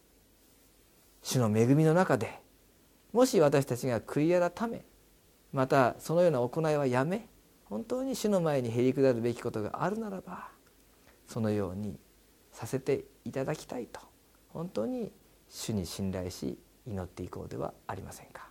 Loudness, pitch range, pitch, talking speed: -31 LUFS, 115-180 Hz, 135 Hz, 285 characters per minute